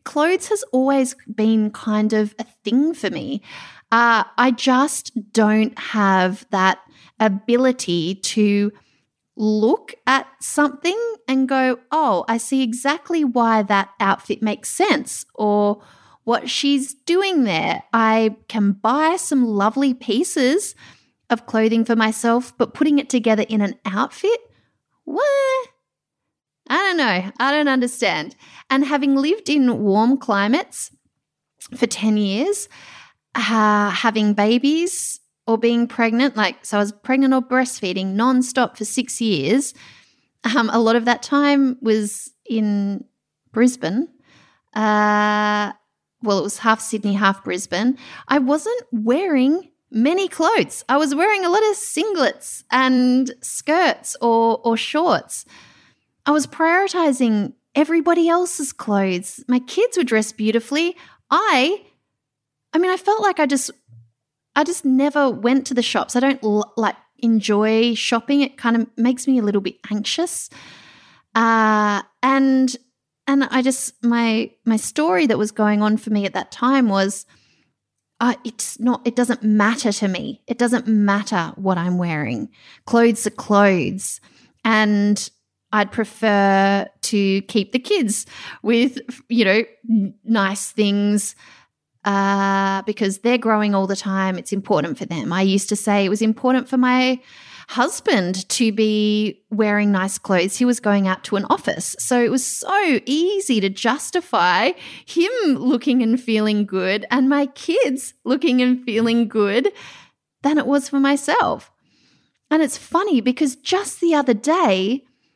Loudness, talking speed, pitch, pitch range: -19 LUFS, 145 wpm, 235 Hz, 210-275 Hz